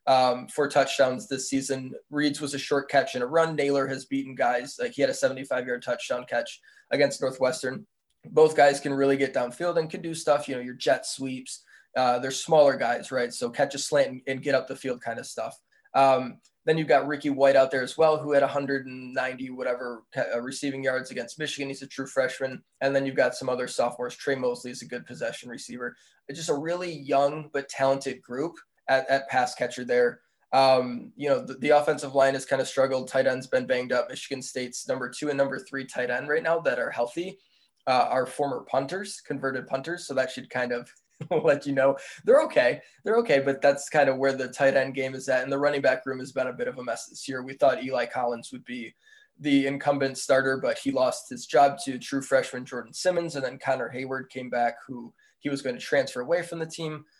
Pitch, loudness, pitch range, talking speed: 135 Hz, -26 LUFS, 130-145 Hz, 225 wpm